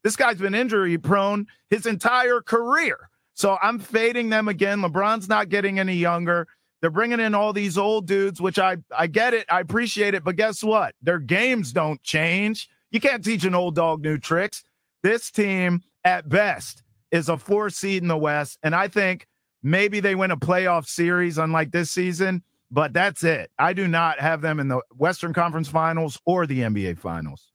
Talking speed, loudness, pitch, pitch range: 190 wpm, -22 LUFS, 185 Hz, 165-210 Hz